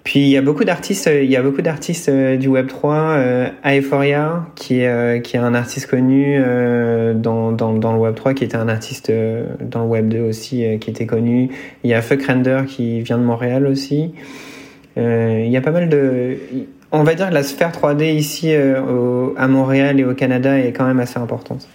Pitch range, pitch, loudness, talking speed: 120-140 Hz, 130 Hz, -16 LUFS, 210 wpm